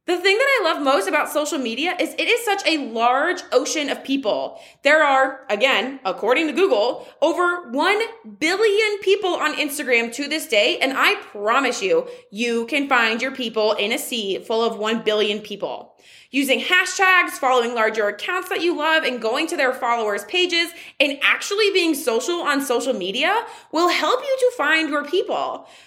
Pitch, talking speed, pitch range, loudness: 295 Hz, 180 wpm, 240-360 Hz, -20 LUFS